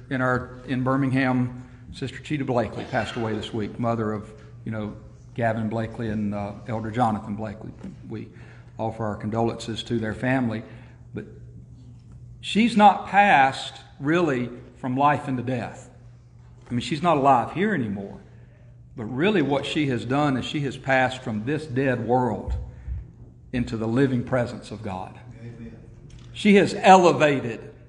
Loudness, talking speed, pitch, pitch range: -23 LUFS, 145 wpm, 120 Hz, 115-135 Hz